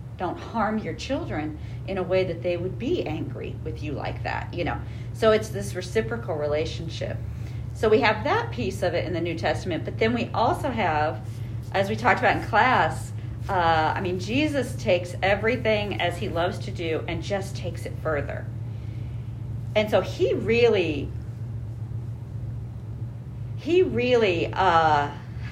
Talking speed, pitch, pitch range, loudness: 160 wpm, 115 Hz, 115-125 Hz, -25 LUFS